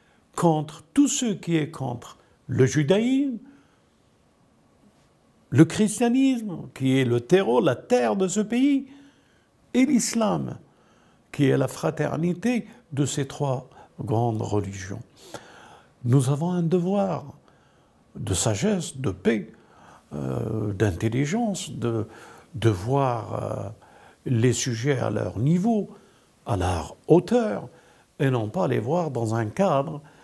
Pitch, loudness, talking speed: 145 Hz, -24 LUFS, 120 wpm